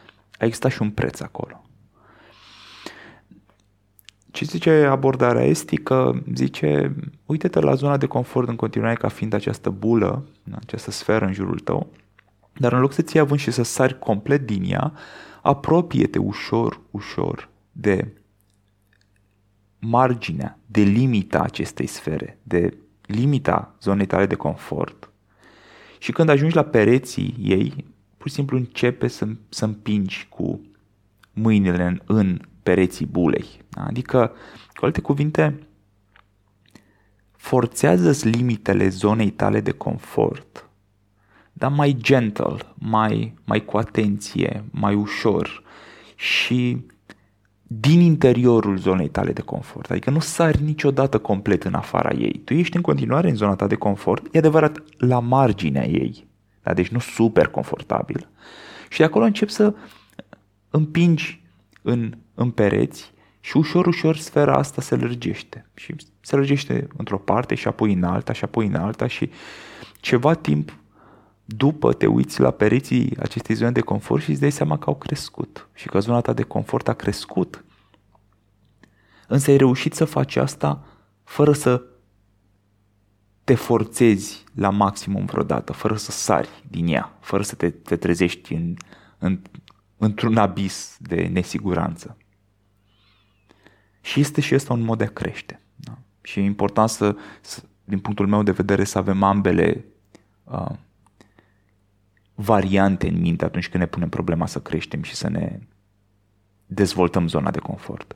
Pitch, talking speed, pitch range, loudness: 105 Hz, 140 wpm, 100-130 Hz, -21 LUFS